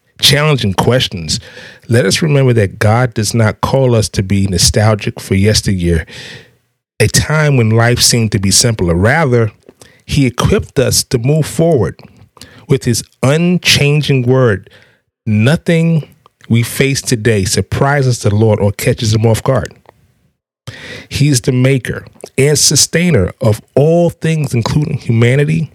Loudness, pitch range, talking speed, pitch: -12 LUFS, 110-145 Hz, 135 wpm, 125 Hz